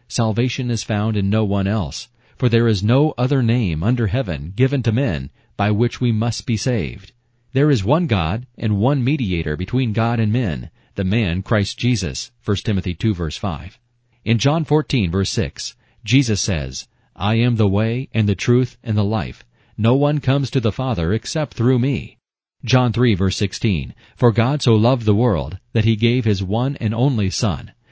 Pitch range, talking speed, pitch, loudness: 100-125 Hz, 185 wpm, 115 Hz, -19 LUFS